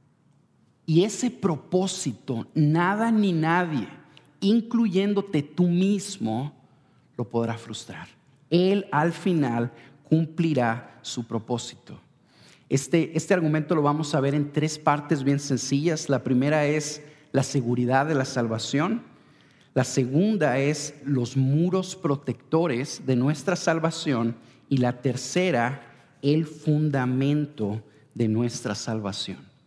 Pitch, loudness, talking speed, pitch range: 145 Hz, -25 LUFS, 110 wpm, 125-165 Hz